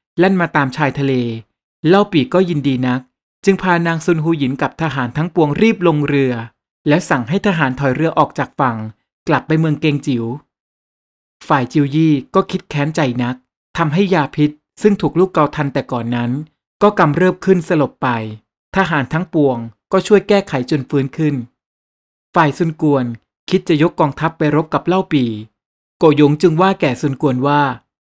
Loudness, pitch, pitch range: -16 LUFS, 150 Hz, 130-170 Hz